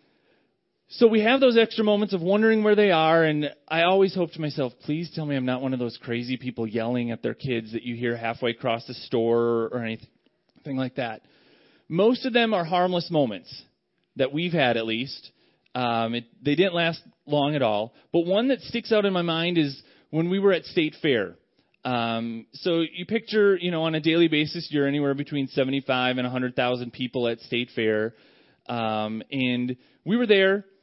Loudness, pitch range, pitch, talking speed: -24 LUFS, 120-175 Hz, 140 Hz, 195 wpm